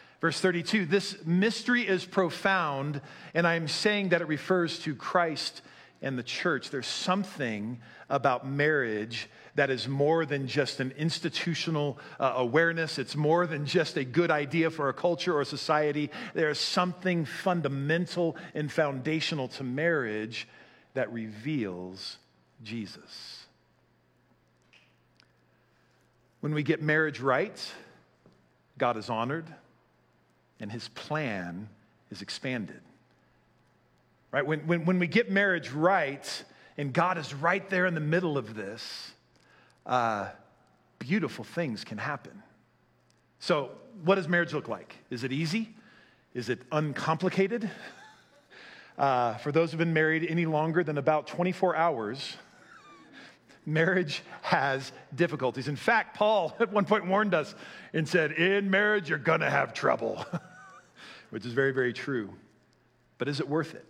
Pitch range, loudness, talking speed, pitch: 135-180 Hz, -29 LUFS, 135 wpm, 155 Hz